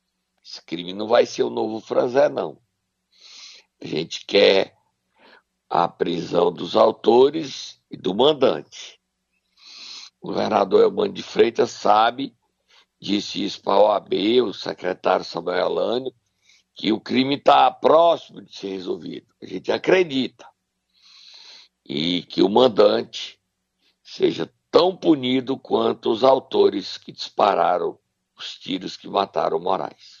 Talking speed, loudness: 125 wpm, -20 LUFS